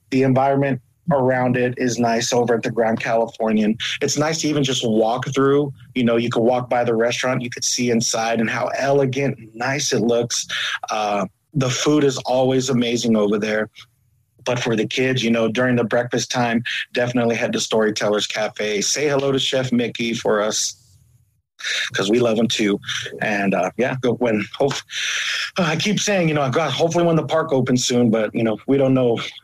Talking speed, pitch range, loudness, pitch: 200 wpm, 115-135 Hz, -19 LUFS, 120 Hz